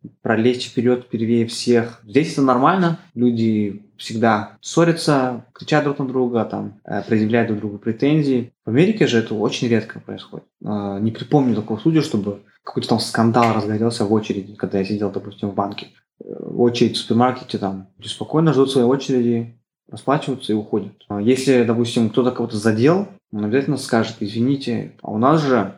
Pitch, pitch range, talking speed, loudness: 115 Hz, 110-130 Hz, 160 wpm, -19 LUFS